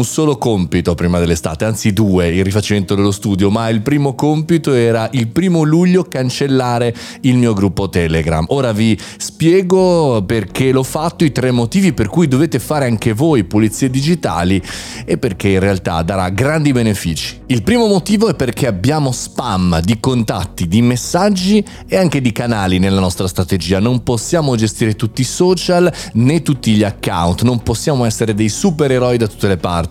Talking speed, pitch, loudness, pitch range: 170 wpm, 120 Hz, -14 LUFS, 100-145 Hz